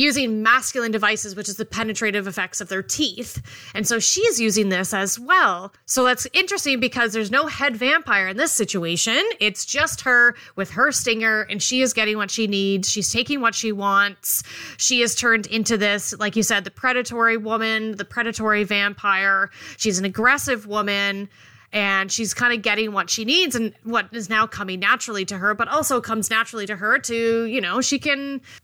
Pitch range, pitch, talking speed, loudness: 205-250 Hz, 225 Hz, 195 wpm, -20 LUFS